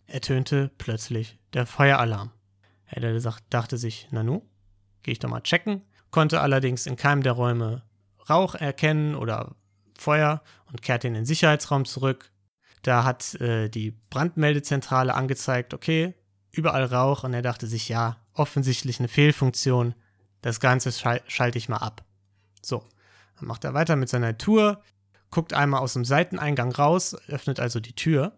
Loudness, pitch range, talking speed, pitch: -25 LUFS, 115-145 Hz, 150 wpm, 125 Hz